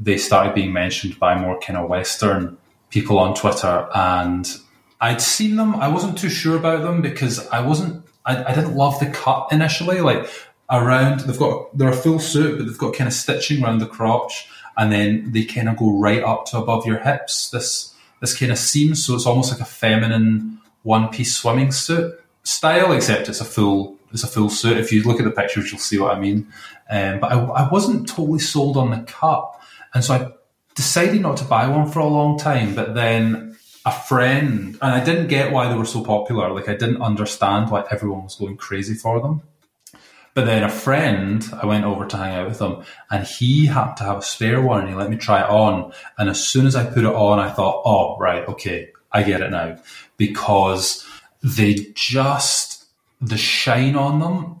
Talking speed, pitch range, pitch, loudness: 210 wpm, 105-140 Hz, 115 Hz, -19 LUFS